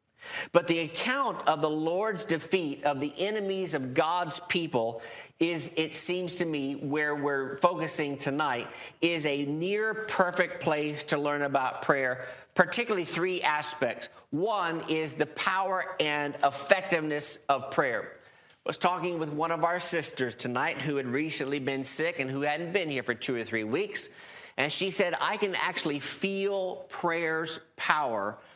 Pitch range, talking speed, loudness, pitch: 145-180 Hz, 160 wpm, -29 LUFS, 160 Hz